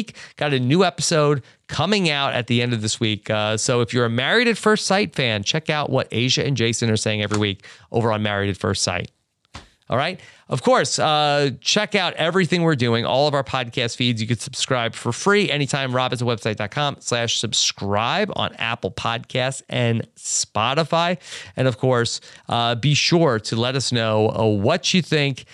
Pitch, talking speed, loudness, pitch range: 125 Hz, 190 wpm, -20 LUFS, 115-150 Hz